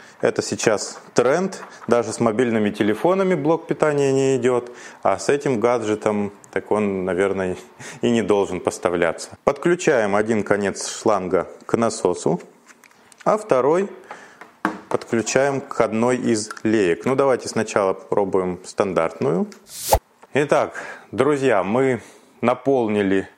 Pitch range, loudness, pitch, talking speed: 105-135 Hz, -21 LUFS, 115 Hz, 115 wpm